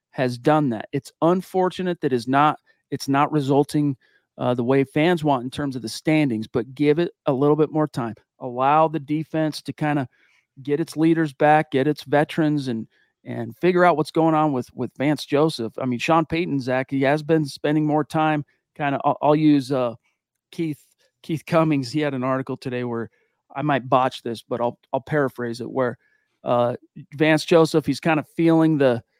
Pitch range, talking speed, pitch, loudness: 130-155 Hz, 200 wpm, 145 Hz, -22 LUFS